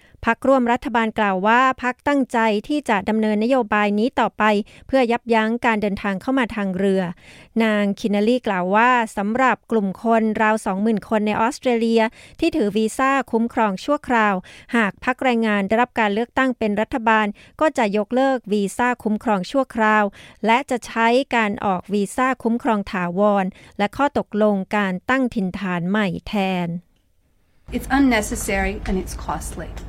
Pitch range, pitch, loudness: 205-245 Hz, 220 Hz, -20 LUFS